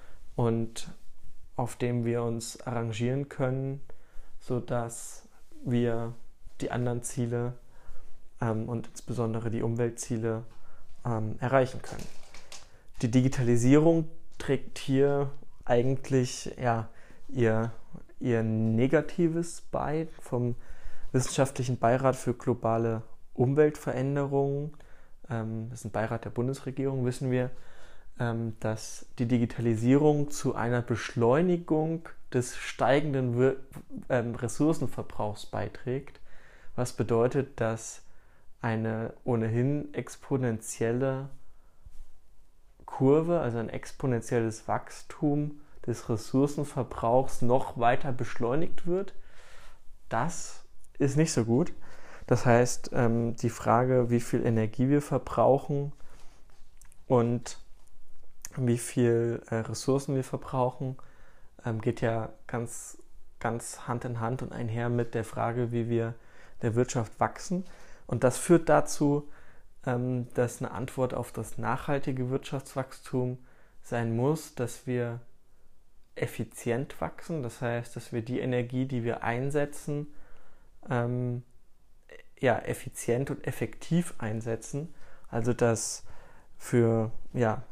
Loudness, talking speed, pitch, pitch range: -30 LUFS, 100 wpm, 120 Hz, 115-135 Hz